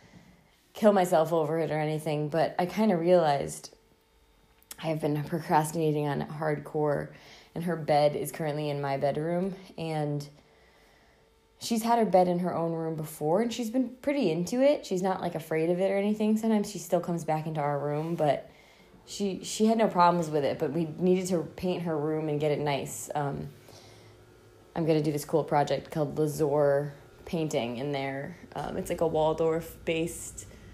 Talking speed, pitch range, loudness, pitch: 185 wpm, 145-180 Hz, -29 LUFS, 160 Hz